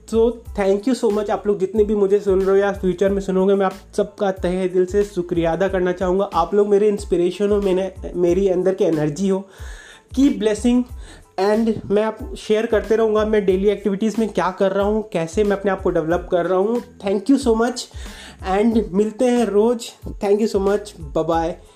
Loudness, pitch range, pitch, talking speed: -19 LUFS, 190-215 Hz, 200 Hz, 205 wpm